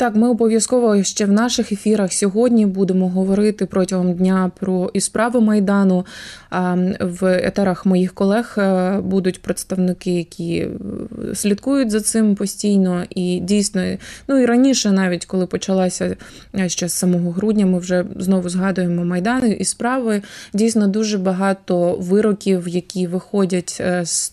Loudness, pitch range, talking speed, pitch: -18 LUFS, 185-210 Hz, 130 wpm, 195 Hz